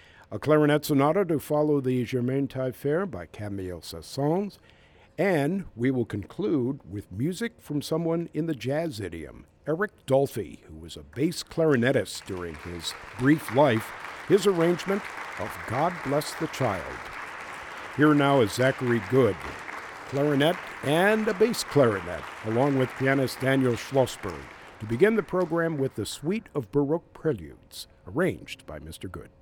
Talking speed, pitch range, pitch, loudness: 145 wpm, 105-160 Hz, 135 Hz, -26 LUFS